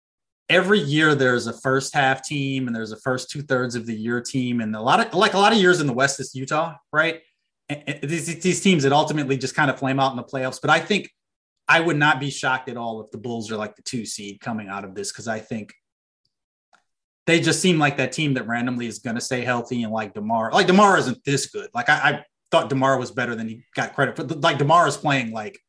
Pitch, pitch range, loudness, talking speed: 135 Hz, 125-160 Hz, -21 LUFS, 255 wpm